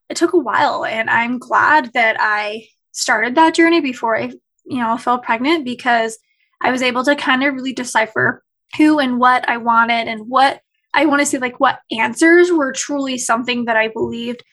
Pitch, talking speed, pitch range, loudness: 255 Hz, 190 wpm, 235-300 Hz, -16 LUFS